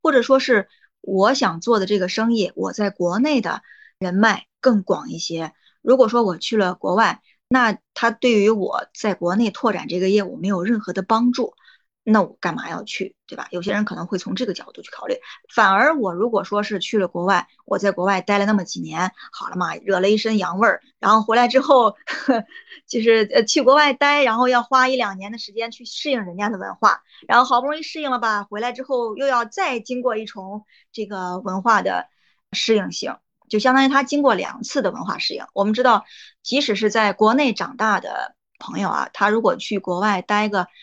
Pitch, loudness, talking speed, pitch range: 220 Hz, -20 LUFS, 300 characters per minute, 200-250 Hz